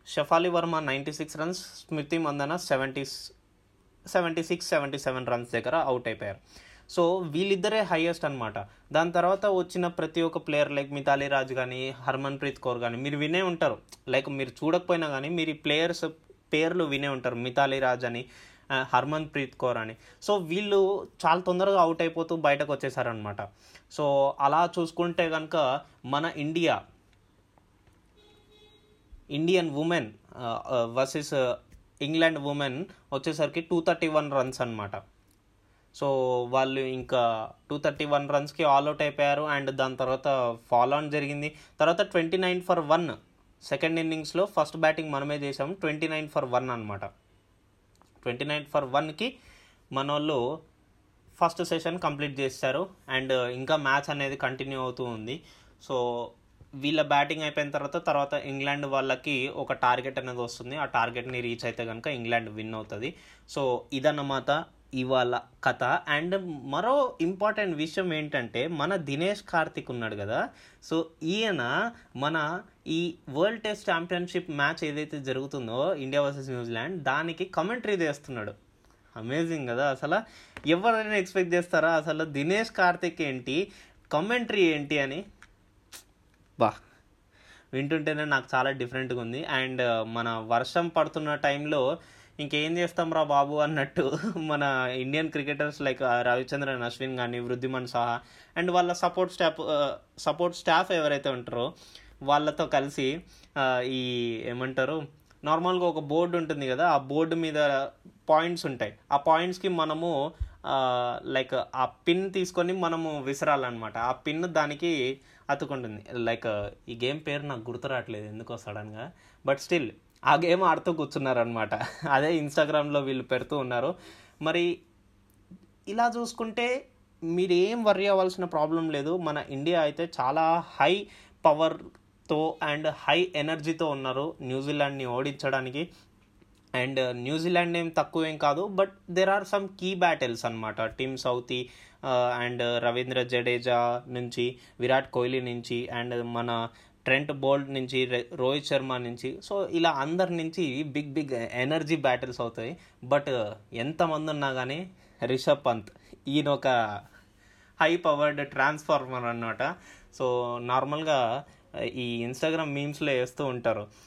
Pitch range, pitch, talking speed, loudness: 125-160 Hz, 140 Hz, 125 wpm, -28 LUFS